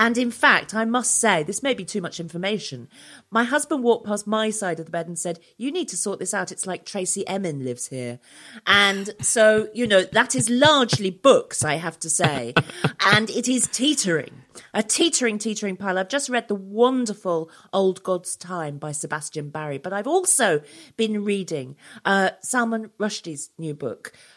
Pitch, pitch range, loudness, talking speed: 200 Hz, 165-230 Hz, -22 LUFS, 185 wpm